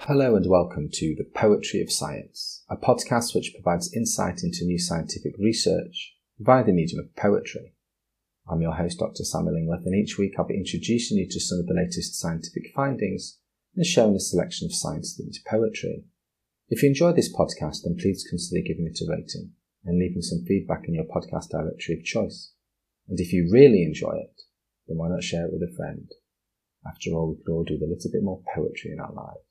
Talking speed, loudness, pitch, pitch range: 205 wpm, -25 LUFS, 90 Hz, 85-115 Hz